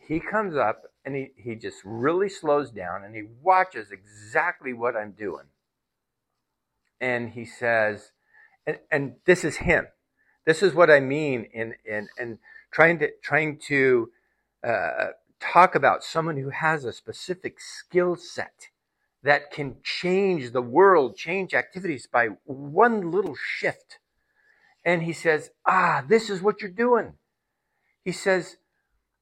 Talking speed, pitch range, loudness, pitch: 140 wpm, 125-195 Hz, -24 LUFS, 160 Hz